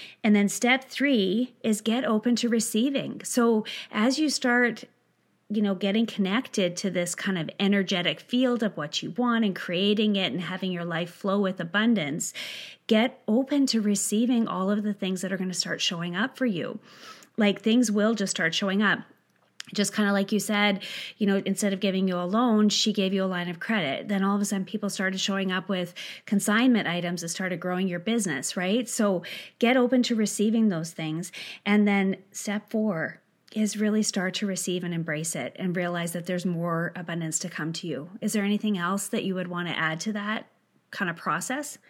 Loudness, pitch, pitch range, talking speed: -26 LUFS, 200 Hz, 185-225 Hz, 205 wpm